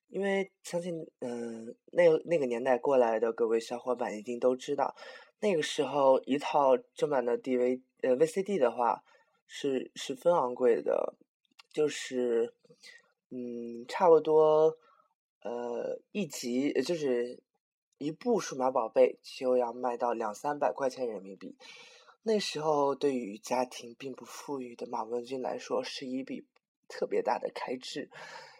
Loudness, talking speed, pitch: -31 LUFS, 215 characters per minute, 145 Hz